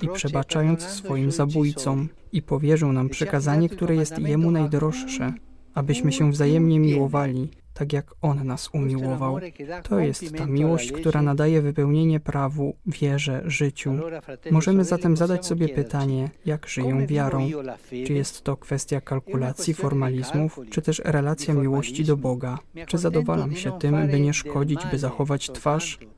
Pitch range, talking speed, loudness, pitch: 135-160 Hz, 140 wpm, -24 LUFS, 145 Hz